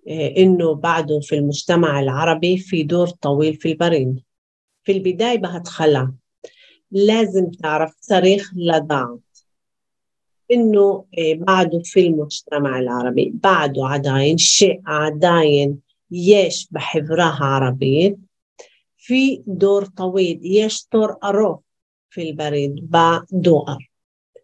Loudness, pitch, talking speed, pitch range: -17 LUFS, 165 Hz, 95 wpm, 145-190 Hz